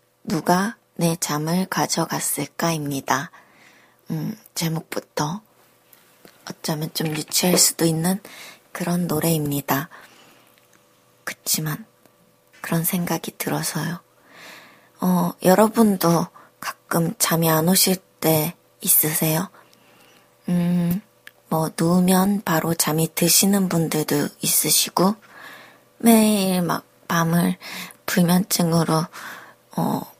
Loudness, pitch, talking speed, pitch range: -21 LUFS, 170 Hz, 190 characters per minute, 160-185 Hz